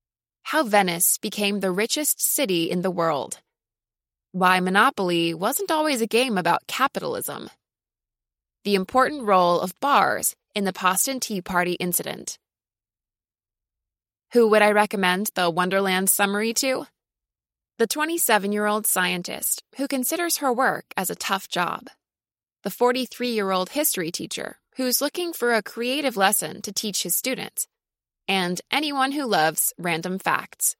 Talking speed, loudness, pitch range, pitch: 140 wpm, -22 LUFS, 180-255 Hz, 205 Hz